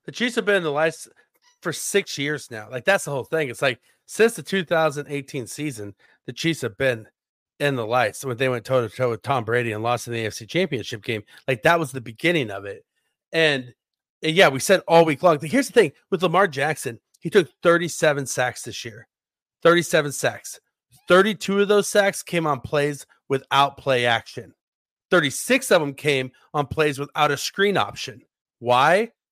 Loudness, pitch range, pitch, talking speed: -22 LUFS, 130-190 Hz, 150 Hz, 195 wpm